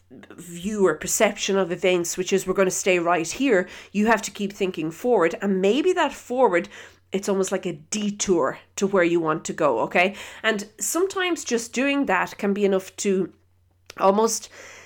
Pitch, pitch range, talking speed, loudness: 195 Hz, 180-220 Hz, 180 wpm, -23 LUFS